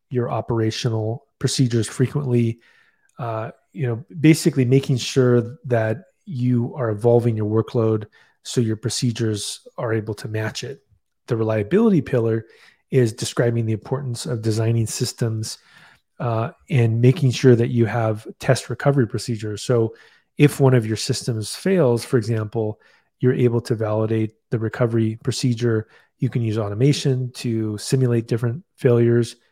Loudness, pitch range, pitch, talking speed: -21 LUFS, 110-130 Hz, 120 Hz, 140 wpm